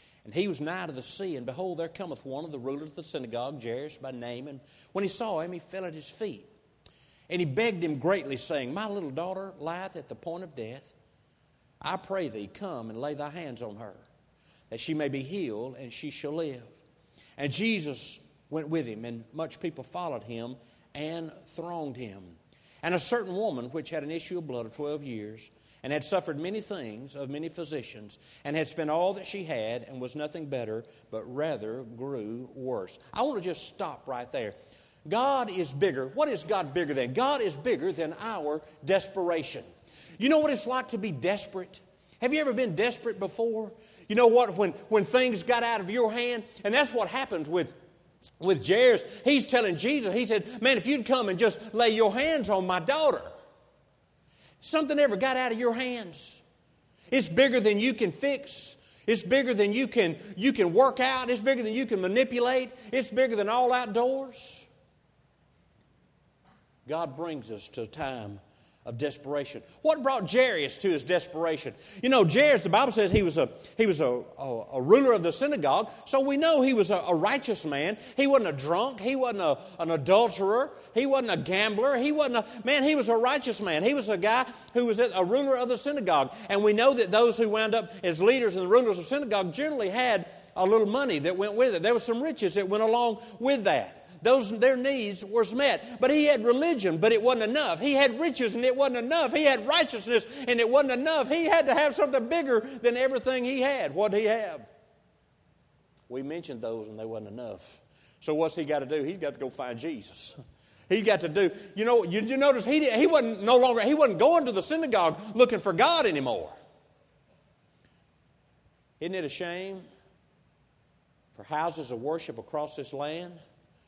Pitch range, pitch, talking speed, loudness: 155-250 Hz, 200 Hz, 205 wpm, -27 LUFS